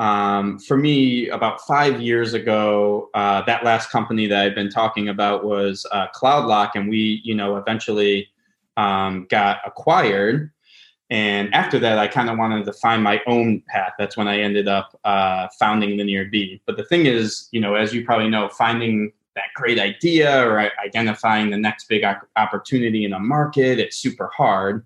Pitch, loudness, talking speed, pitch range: 105 Hz, -19 LUFS, 175 wpm, 100-115 Hz